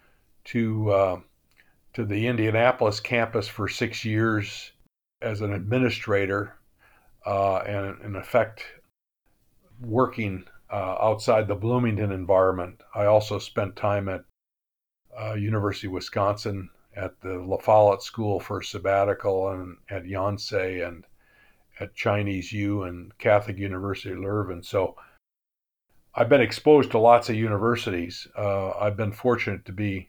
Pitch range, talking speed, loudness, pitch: 95-110 Hz, 130 wpm, -25 LUFS, 100 Hz